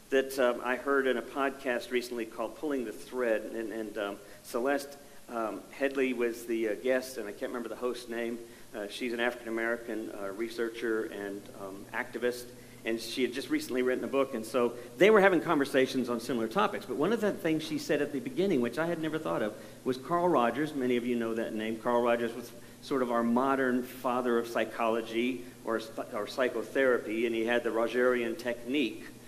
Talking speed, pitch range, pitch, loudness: 205 wpm, 115-130 Hz, 120 Hz, -31 LUFS